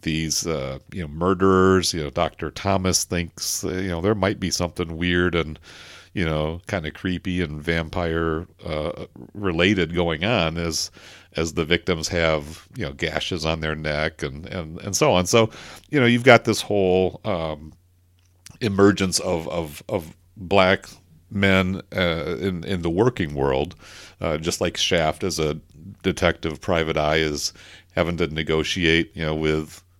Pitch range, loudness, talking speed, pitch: 80-95 Hz, -22 LUFS, 160 wpm, 85 Hz